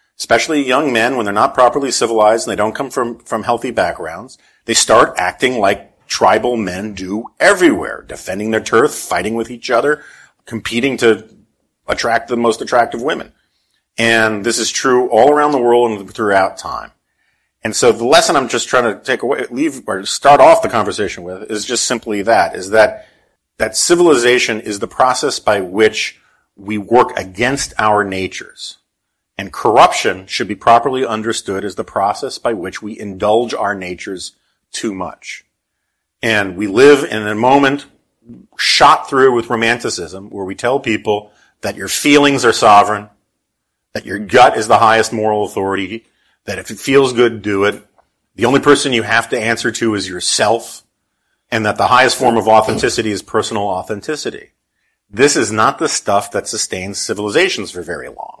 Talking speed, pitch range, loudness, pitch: 170 wpm, 105-120 Hz, -14 LUFS, 110 Hz